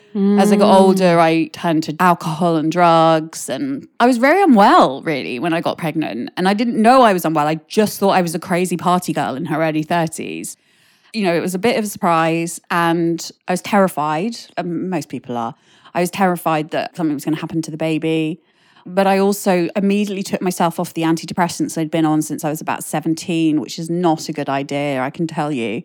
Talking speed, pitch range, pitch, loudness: 220 wpm, 160-190 Hz, 170 Hz, -17 LUFS